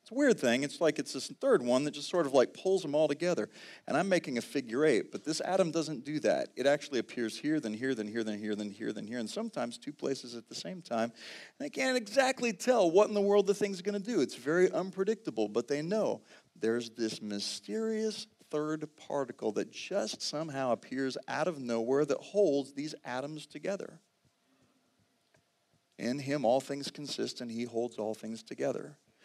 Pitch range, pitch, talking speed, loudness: 120-195 Hz, 145 Hz, 205 wpm, -33 LUFS